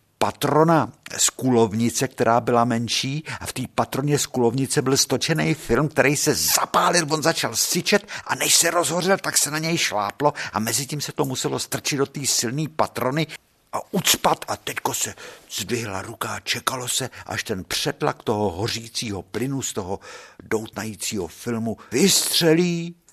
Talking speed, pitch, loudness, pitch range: 160 wpm, 135 Hz, -22 LUFS, 115-155 Hz